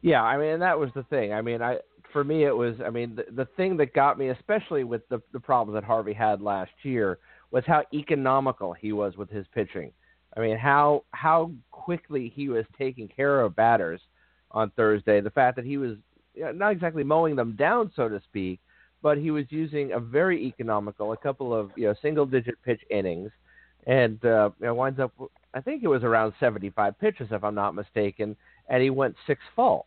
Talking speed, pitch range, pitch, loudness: 220 wpm, 110-145 Hz, 125 Hz, -26 LUFS